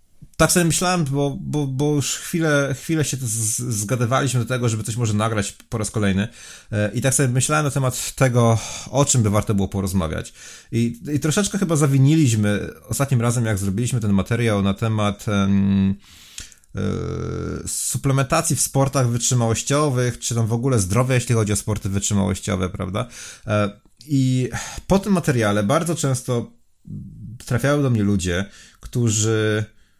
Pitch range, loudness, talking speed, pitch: 105-135 Hz, -20 LUFS, 150 wpm, 120 Hz